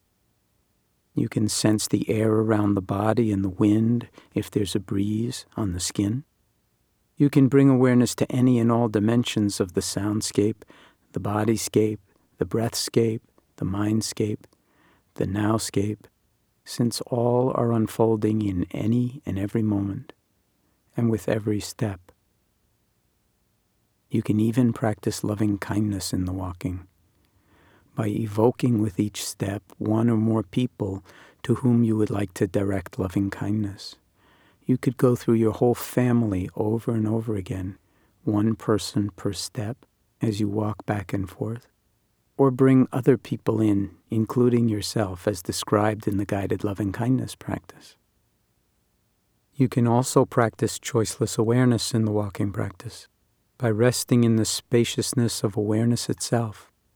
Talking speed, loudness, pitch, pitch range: 140 wpm, -24 LUFS, 110 Hz, 100-120 Hz